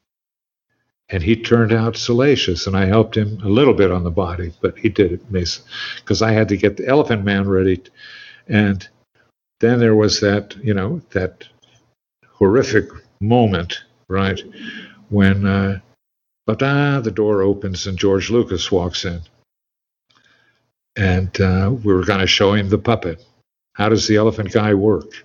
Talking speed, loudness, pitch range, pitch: 155 wpm, -17 LUFS, 95-110 Hz, 100 Hz